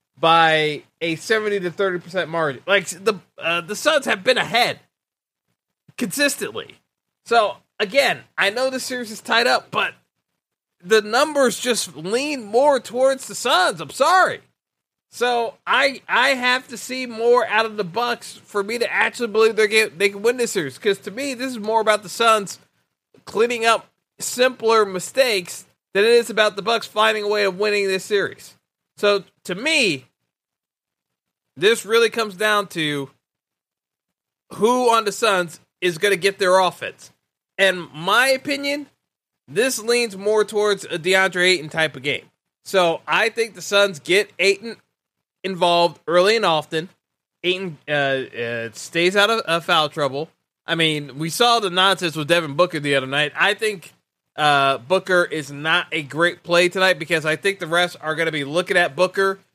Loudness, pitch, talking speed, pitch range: -19 LUFS, 195 Hz, 170 wpm, 170-225 Hz